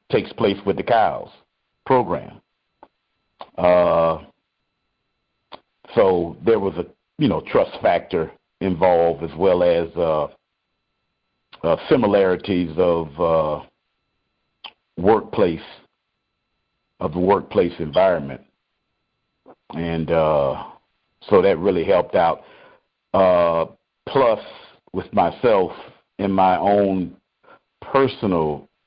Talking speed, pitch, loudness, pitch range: 90 wpm, 85 Hz, -19 LUFS, 80-95 Hz